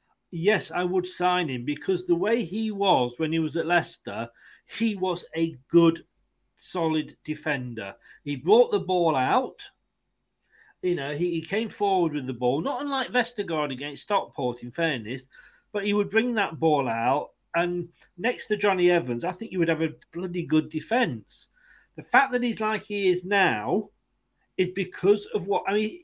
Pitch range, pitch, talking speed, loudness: 155-205 Hz, 175 Hz, 175 wpm, -26 LUFS